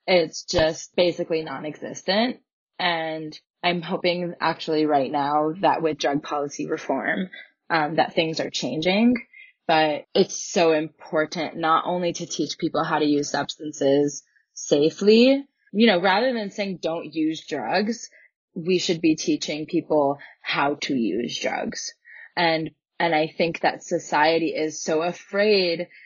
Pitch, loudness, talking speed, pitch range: 165 Hz, -23 LUFS, 140 wpm, 155-185 Hz